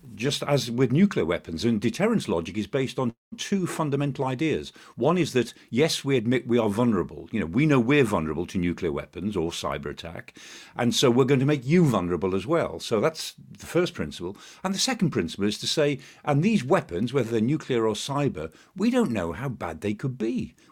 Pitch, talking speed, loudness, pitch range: 135 Hz, 210 wpm, -25 LUFS, 115-155 Hz